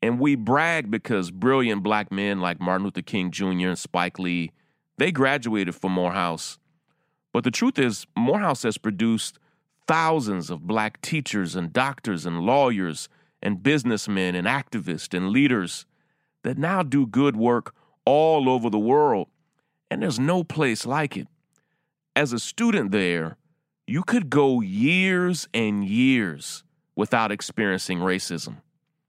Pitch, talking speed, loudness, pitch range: 130 Hz, 140 wpm, -23 LUFS, 100-160 Hz